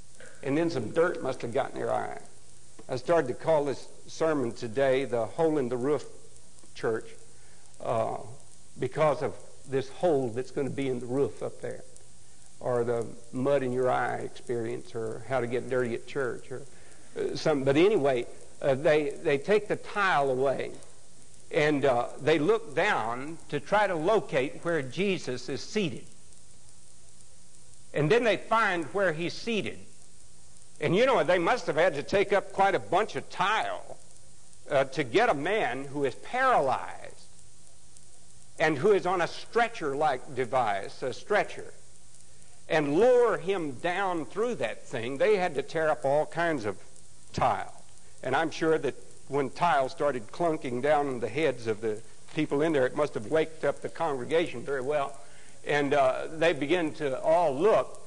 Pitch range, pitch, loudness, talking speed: 110-170 Hz, 140 Hz, -28 LUFS, 165 wpm